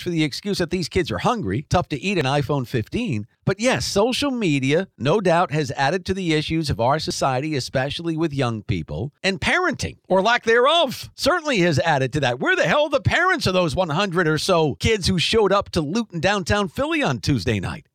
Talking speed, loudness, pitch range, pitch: 215 wpm, -21 LUFS, 140-195 Hz, 165 Hz